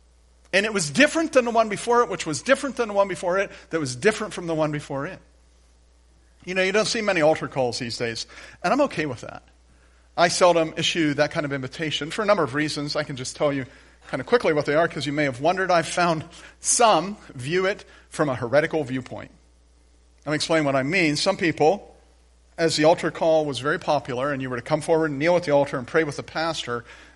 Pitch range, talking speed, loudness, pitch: 130-180 Hz, 240 wpm, -23 LUFS, 155 Hz